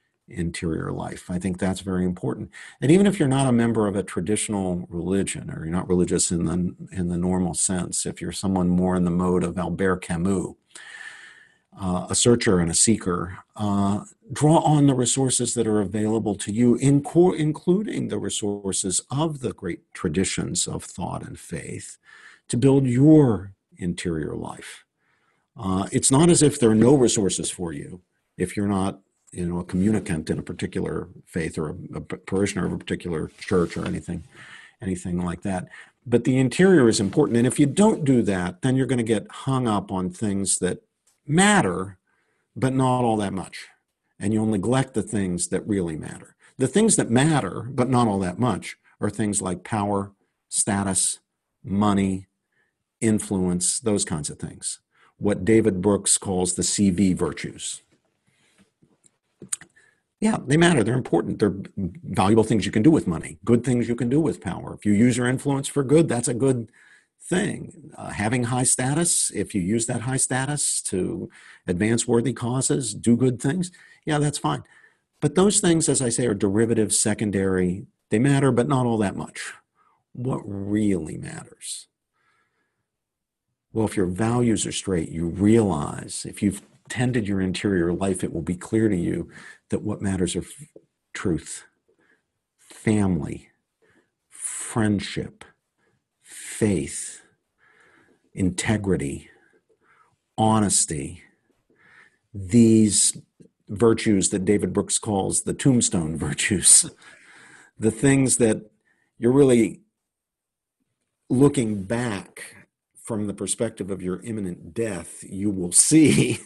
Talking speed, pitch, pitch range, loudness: 155 wpm, 110 Hz, 95-125 Hz, -22 LUFS